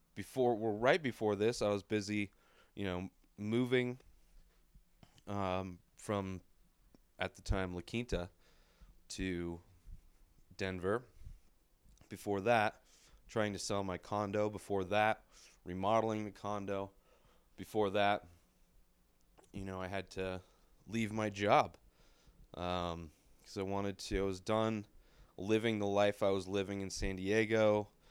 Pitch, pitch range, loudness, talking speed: 100 Hz, 90-105 Hz, -37 LUFS, 125 wpm